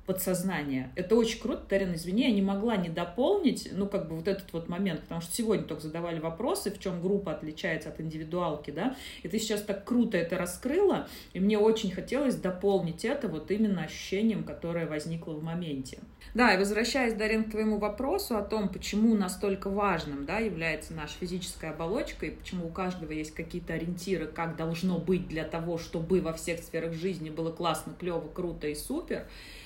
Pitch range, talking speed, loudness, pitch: 165-205 Hz, 185 wpm, -31 LUFS, 185 Hz